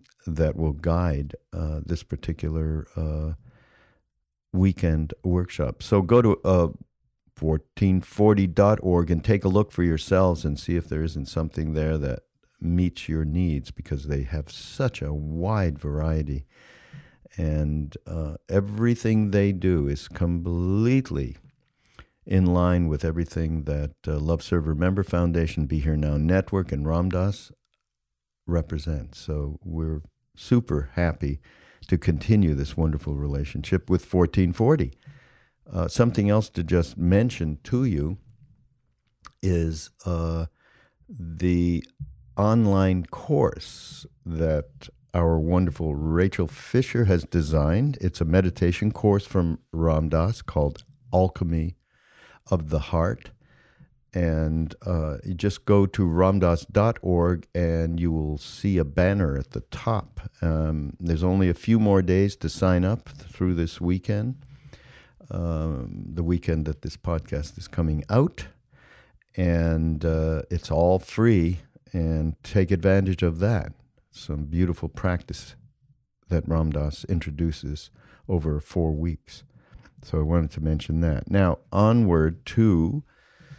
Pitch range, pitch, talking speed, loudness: 80-95 Hz, 85 Hz, 125 wpm, -25 LUFS